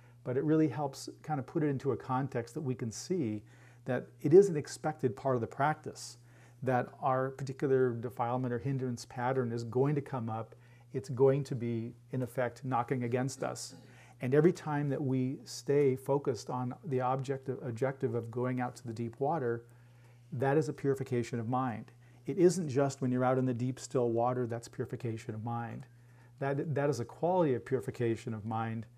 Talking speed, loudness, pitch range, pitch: 195 wpm, -33 LUFS, 120-135 Hz, 125 Hz